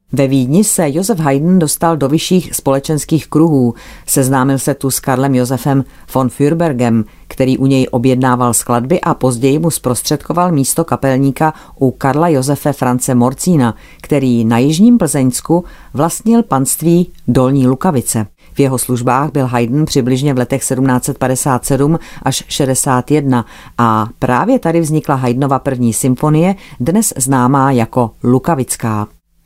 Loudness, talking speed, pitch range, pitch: -13 LUFS, 130 wpm, 125-155 Hz, 135 Hz